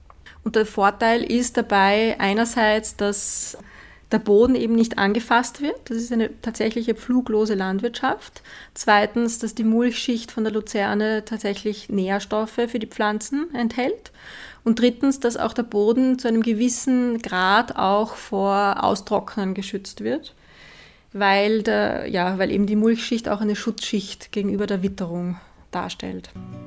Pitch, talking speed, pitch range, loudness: 220 Hz, 135 wpm, 200-235 Hz, -22 LUFS